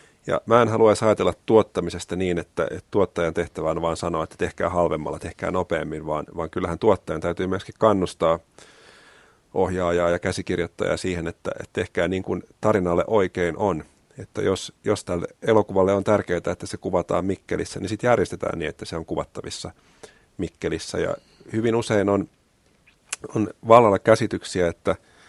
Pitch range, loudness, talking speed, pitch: 85-105 Hz, -23 LUFS, 155 wpm, 90 Hz